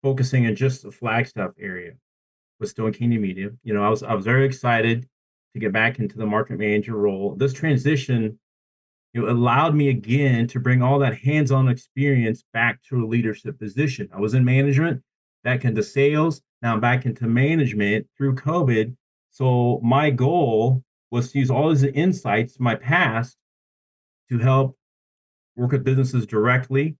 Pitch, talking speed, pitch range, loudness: 125 Hz, 170 wpm, 110-135 Hz, -21 LUFS